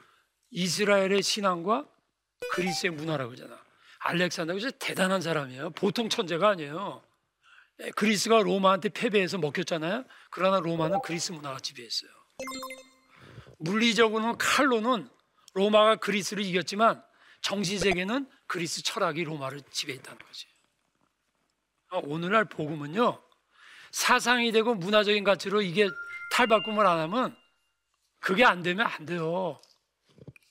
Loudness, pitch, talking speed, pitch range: -27 LUFS, 195 Hz, 300 characters per minute, 170-225 Hz